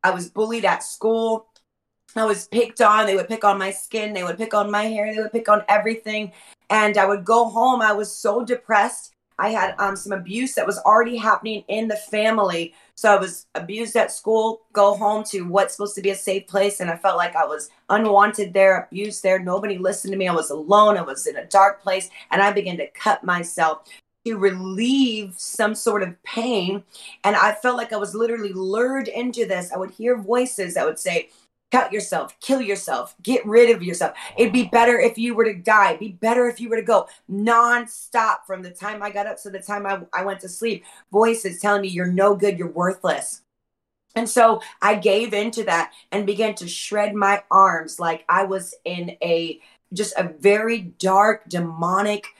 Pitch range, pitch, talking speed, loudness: 190-225 Hz, 205 Hz, 210 wpm, -20 LUFS